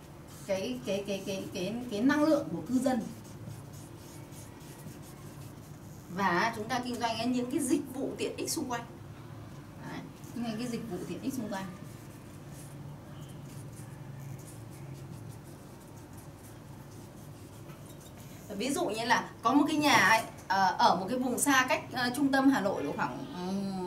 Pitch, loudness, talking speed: 185 Hz, -30 LUFS, 145 wpm